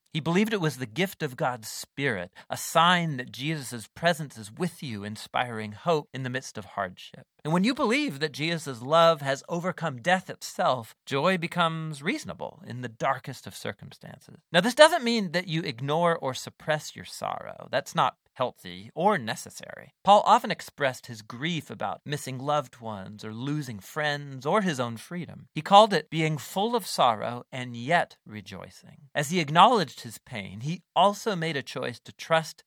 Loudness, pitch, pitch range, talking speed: -27 LUFS, 155 Hz, 125-175 Hz, 180 wpm